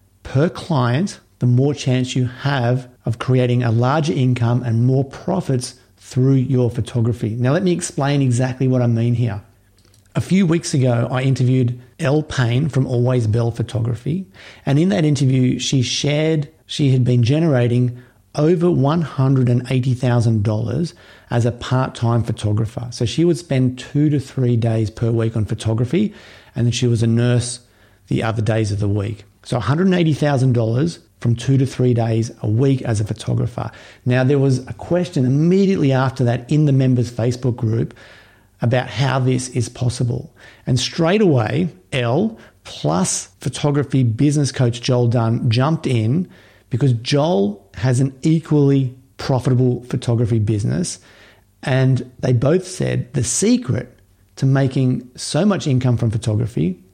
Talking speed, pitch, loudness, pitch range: 150 wpm, 125 Hz, -18 LUFS, 115-135 Hz